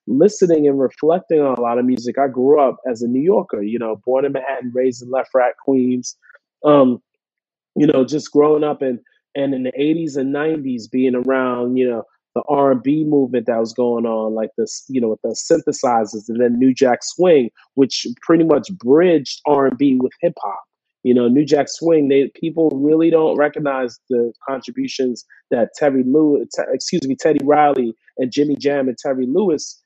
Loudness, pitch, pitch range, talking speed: -17 LUFS, 135 Hz, 125-150 Hz, 200 wpm